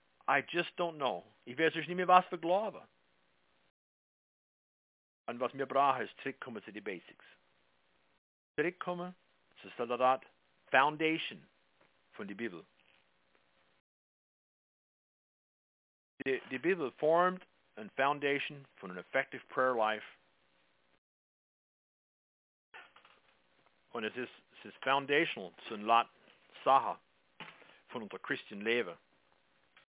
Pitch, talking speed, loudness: 100 Hz, 105 wpm, -34 LUFS